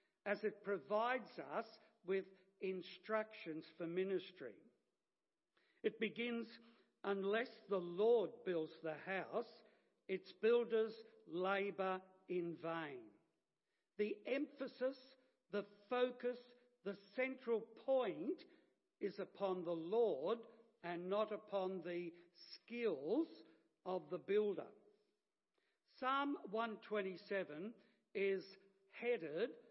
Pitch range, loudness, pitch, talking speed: 185-235 Hz, -43 LUFS, 205 Hz, 90 wpm